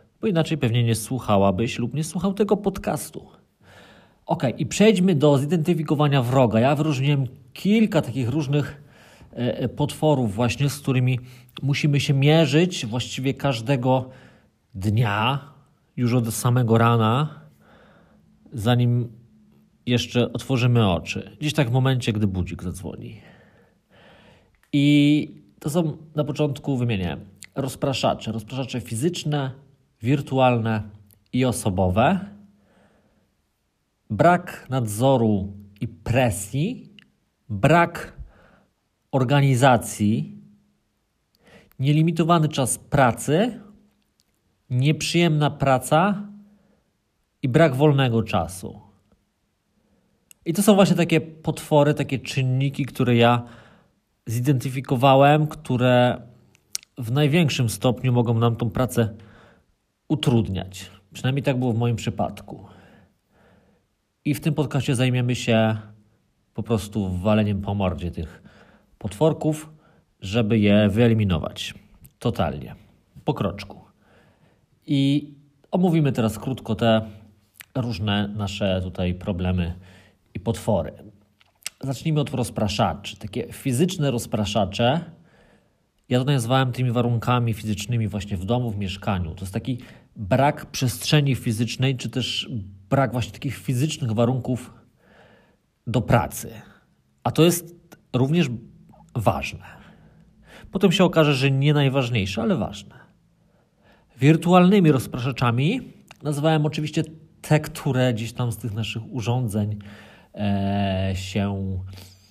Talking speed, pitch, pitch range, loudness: 100 wpm, 125 Hz, 110-145 Hz, -22 LUFS